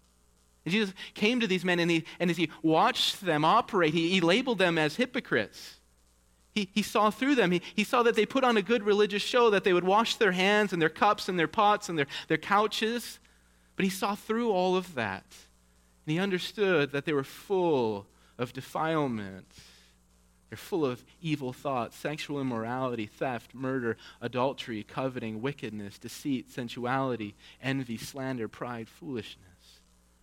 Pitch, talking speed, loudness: 150 Hz, 170 wpm, -29 LUFS